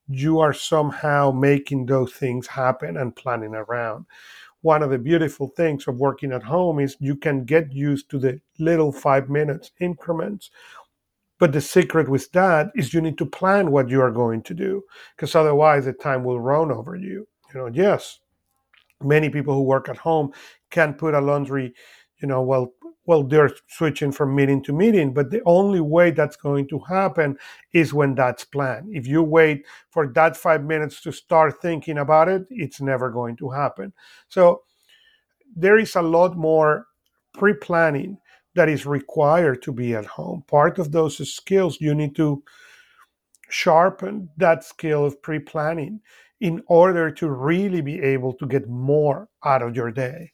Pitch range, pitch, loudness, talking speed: 140-170 Hz, 150 Hz, -21 LUFS, 175 wpm